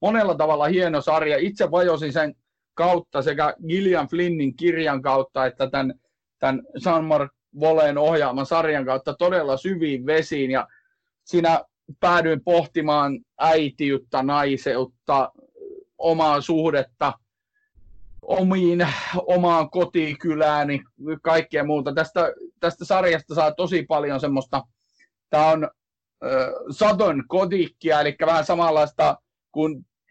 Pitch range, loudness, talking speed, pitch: 145-175 Hz, -22 LUFS, 110 wpm, 155 Hz